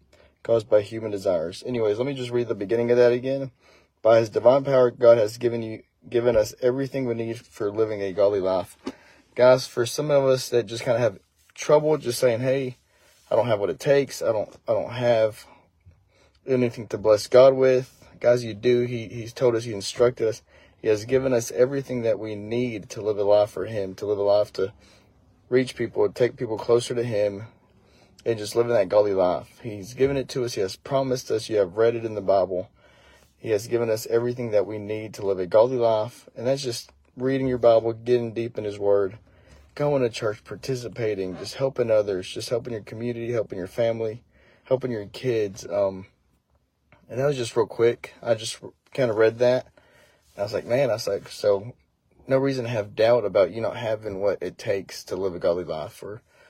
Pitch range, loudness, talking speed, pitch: 105-125 Hz, -24 LUFS, 215 wpm, 115 Hz